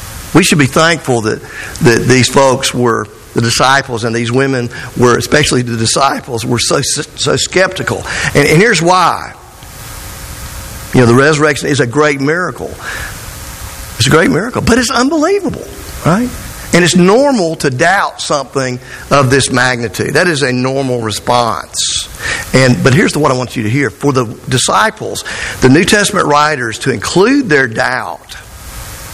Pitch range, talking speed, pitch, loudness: 120-150 Hz, 160 wpm, 130 Hz, -11 LUFS